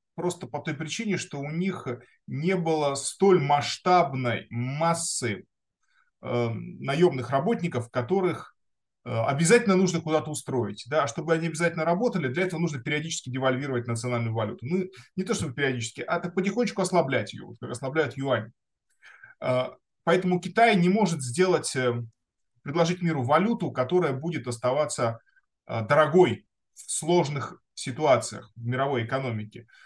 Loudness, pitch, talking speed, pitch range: -26 LUFS, 155 Hz, 135 wpm, 125-180 Hz